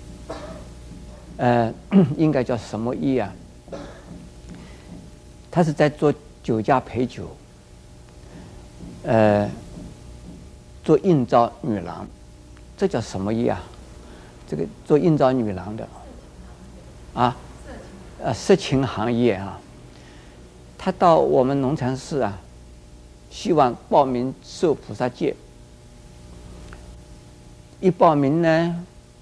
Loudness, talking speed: -21 LUFS, 130 characters per minute